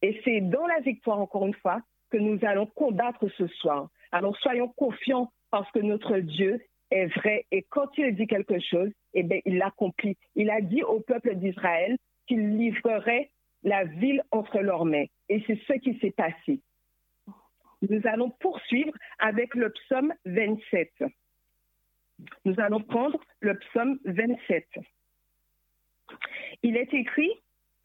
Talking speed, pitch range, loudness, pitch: 145 wpm, 195-250 Hz, -28 LUFS, 220 Hz